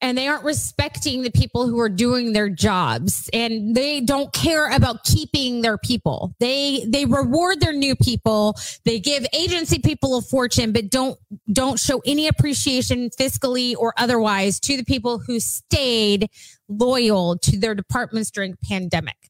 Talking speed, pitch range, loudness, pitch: 160 wpm, 220-265 Hz, -20 LUFS, 245 Hz